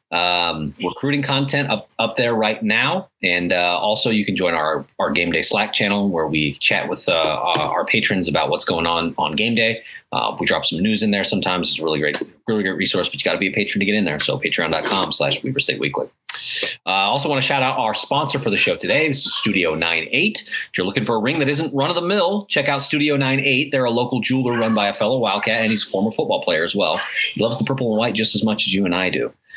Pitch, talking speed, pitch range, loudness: 115 Hz, 260 wpm, 100-140 Hz, -18 LUFS